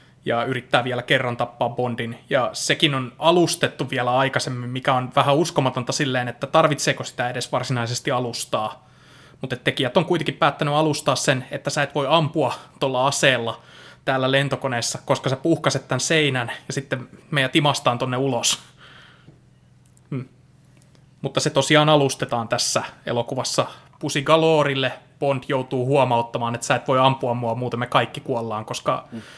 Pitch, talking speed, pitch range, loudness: 135 Hz, 150 wpm, 125-145 Hz, -21 LUFS